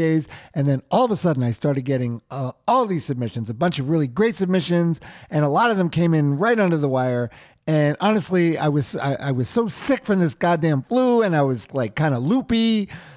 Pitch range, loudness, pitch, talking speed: 135-190 Hz, -21 LUFS, 155 Hz, 230 wpm